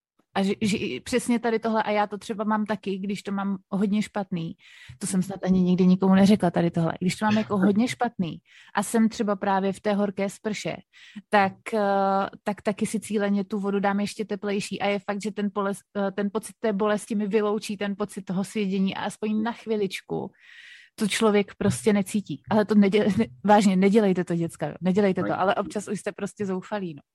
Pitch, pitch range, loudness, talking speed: 205 Hz, 195-215 Hz, -25 LUFS, 200 wpm